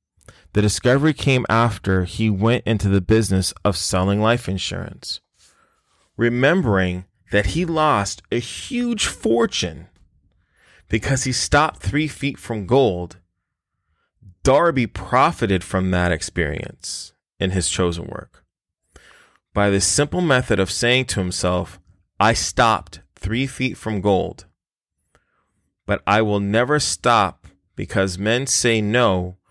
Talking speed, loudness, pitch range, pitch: 120 wpm, -20 LUFS, 90-125 Hz, 105 Hz